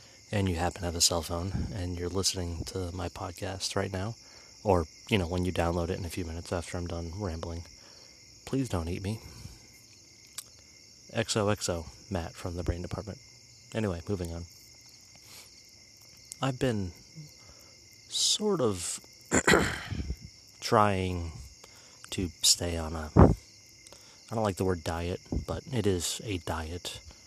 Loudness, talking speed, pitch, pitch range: -30 LUFS, 140 wpm, 95 Hz, 90-110 Hz